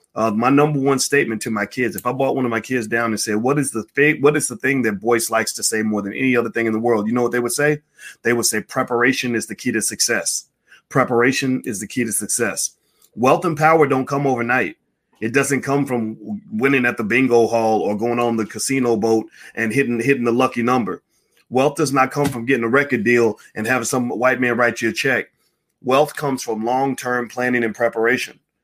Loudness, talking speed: -19 LUFS, 235 wpm